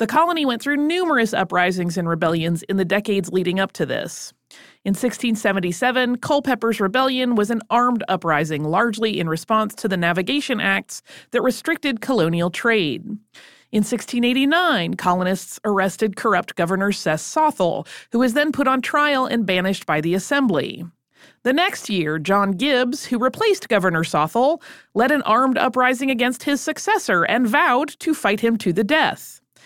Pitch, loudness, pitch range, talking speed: 225 Hz, -20 LUFS, 185-260 Hz, 155 wpm